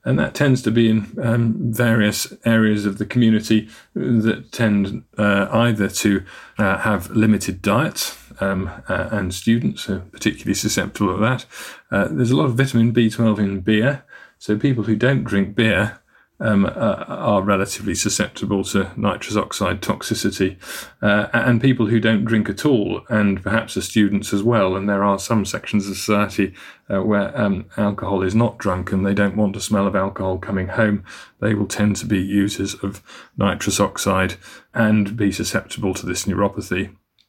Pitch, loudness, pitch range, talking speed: 105 Hz, -20 LUFS, 100-115 Hz, 170 wpm